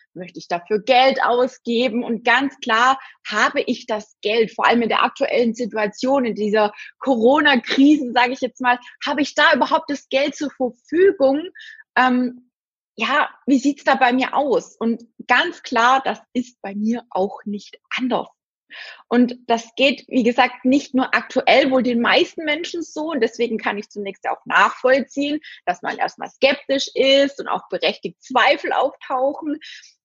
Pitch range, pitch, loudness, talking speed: 235-280 Hz, 255 Hz, -19 LUFS, 165 wpm